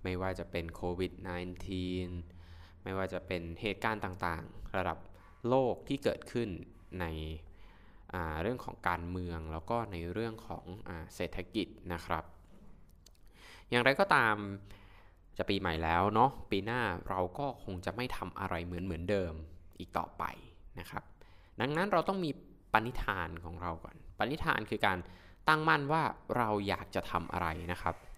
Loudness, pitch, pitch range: -35 LUFS, 90 Hz, 85-105 Hz